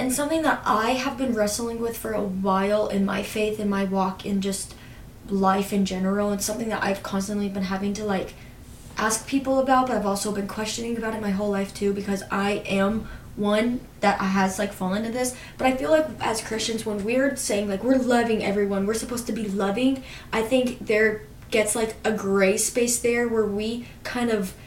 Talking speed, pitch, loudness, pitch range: 210 wpm, 210 Hz, -24 LUFS, 195-230 Hz